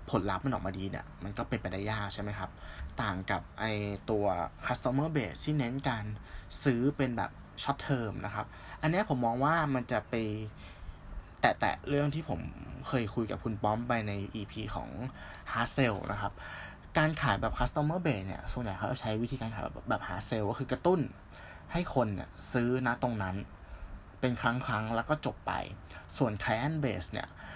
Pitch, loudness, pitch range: 110 Hz, -34 LUFS, 100-130 Hz